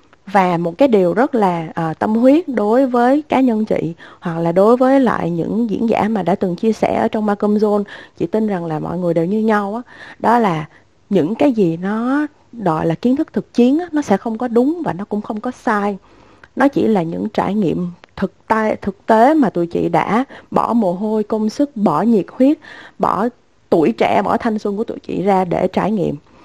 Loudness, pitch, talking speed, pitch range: -17 LUFS, 215 Hz, 225 wpm, 190-240 Hz